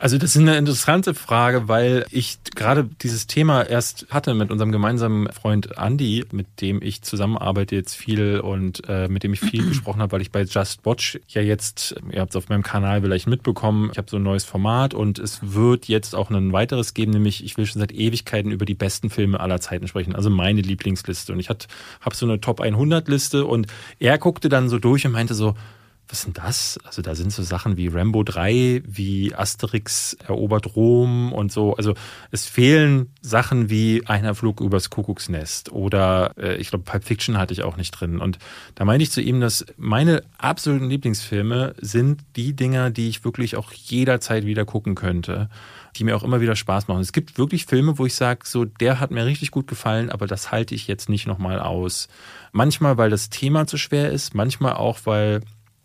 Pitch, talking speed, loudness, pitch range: 110 Hz, 205 wpm, -21 LUFS, 100-125 Hz